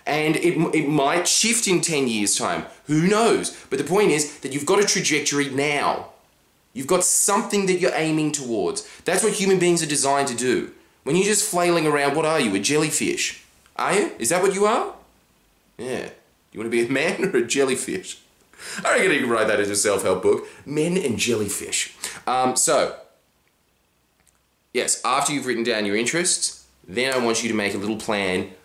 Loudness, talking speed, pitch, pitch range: -21 LUFS, 195 wpm, 150 Hz, 125-180 Hz